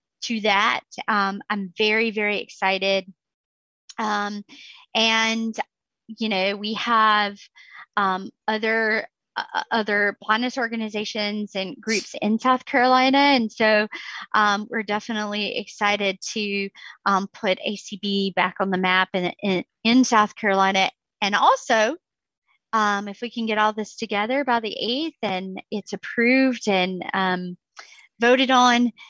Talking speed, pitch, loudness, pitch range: 130 wpm, 215 Hz, -22 LUFS, 200-230 Hz